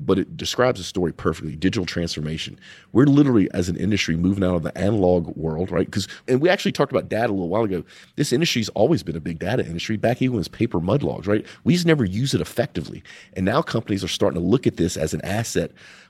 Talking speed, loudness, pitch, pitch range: 245 wpm, -22 LUFS, 100 Hz, 85-120 Hz